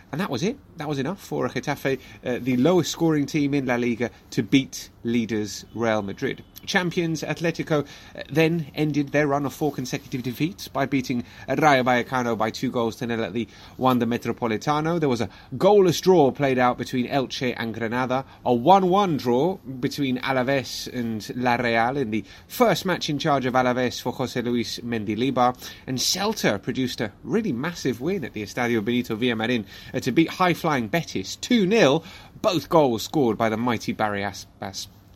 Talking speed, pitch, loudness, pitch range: 175 wpm, 125 Hz, -24 LUFS, 115-145 Hz